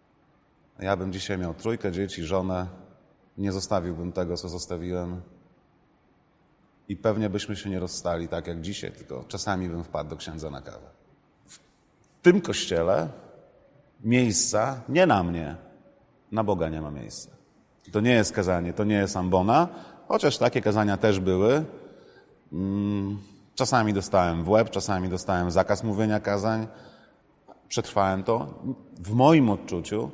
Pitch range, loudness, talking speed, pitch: 90-110 Hz, -26 LUFS, 135 wpm, 100 Hz